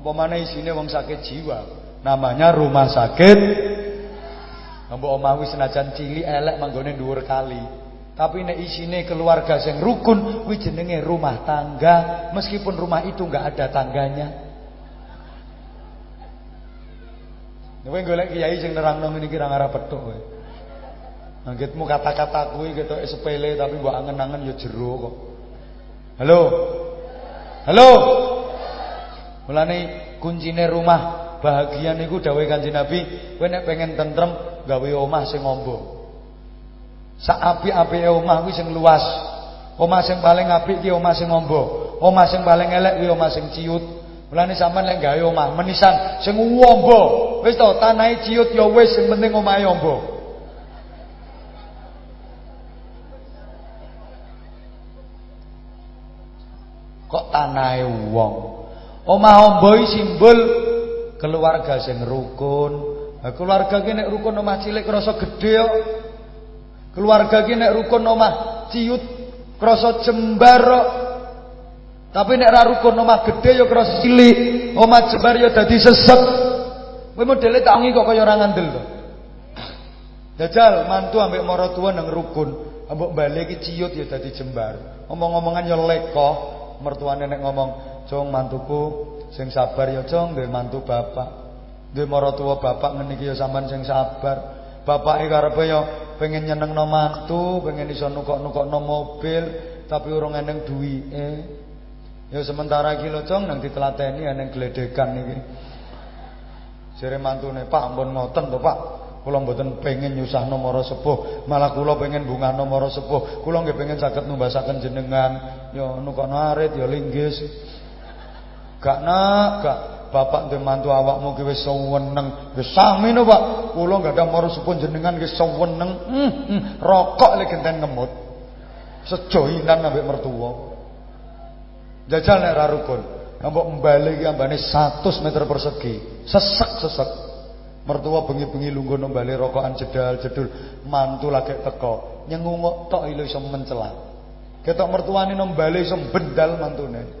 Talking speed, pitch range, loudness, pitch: 130 wpm, 135-185 Hz, -18 LUFS, 155 Hz